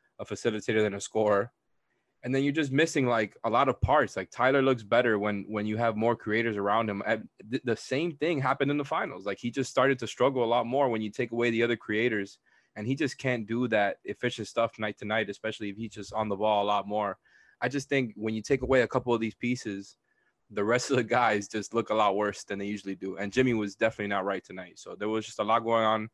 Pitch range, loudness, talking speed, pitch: 105-125 Hz, -29 LUFS, 255 wpm, 110 Hz